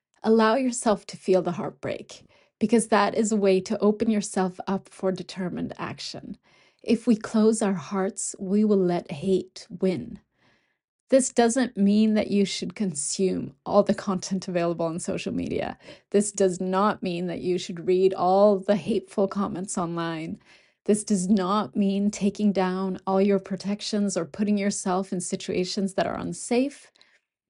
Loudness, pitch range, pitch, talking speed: -25 LUFS, 185-210 Hz, 195 Hz, 155 wpm